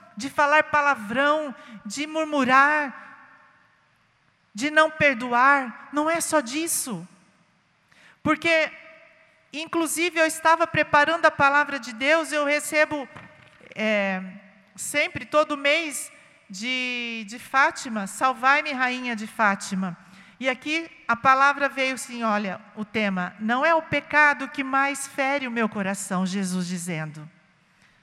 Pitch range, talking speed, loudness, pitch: 215-300 Hz, 120 wpm, -23 LUFS, 275 Hz